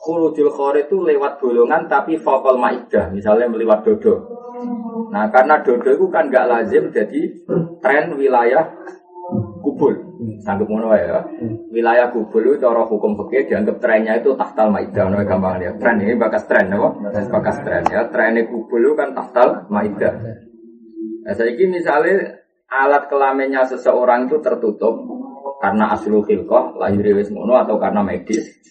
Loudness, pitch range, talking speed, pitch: -17 LUFS, 115-190 Hz, 145 wpm, 135 Hz